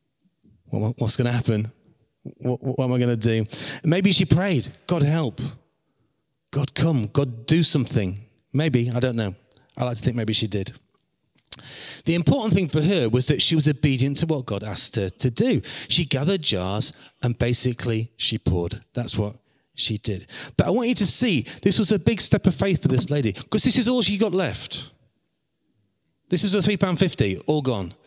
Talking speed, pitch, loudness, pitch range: 190 wpm, 135 Hz, -21 LUFS, 115-160 Hz